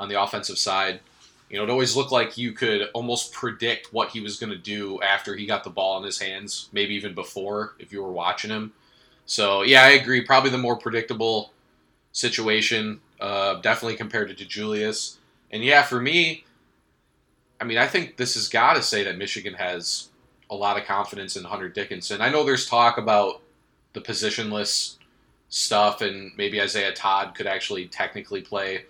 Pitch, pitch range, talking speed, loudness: 105 Hz, 100-120 Hz, 185 wpm, -22 LUFS